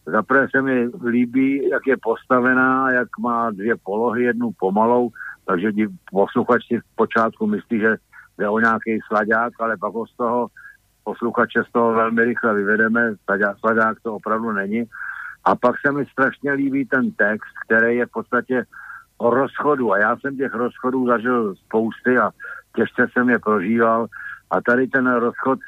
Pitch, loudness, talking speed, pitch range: 120 Hz, -20 LUFS, 160 wpm, 110-125 Hz